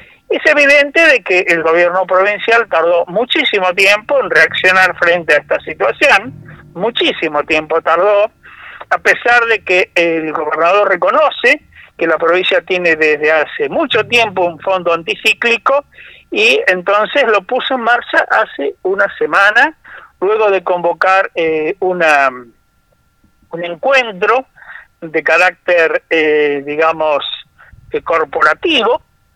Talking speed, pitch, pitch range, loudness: 120 wpm, 185 Hz, 165-235 Hz, -12 LUFS